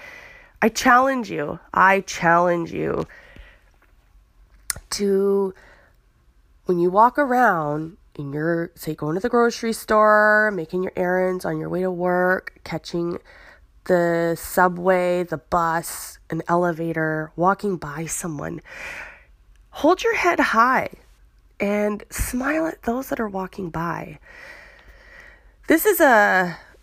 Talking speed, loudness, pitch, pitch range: 115 wpm, -21 LUFS, 185 Hz, 170-245 Hz